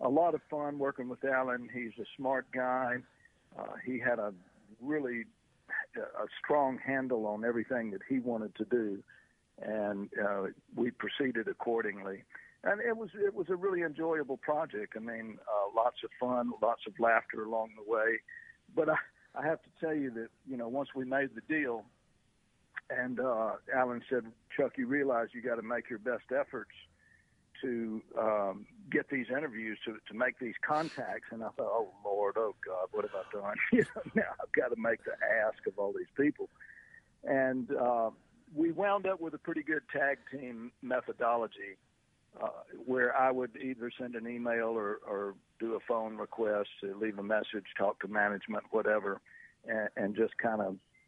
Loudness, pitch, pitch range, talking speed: -35 LUFS, 125 Hz, 115-145 Hz, 180 wpm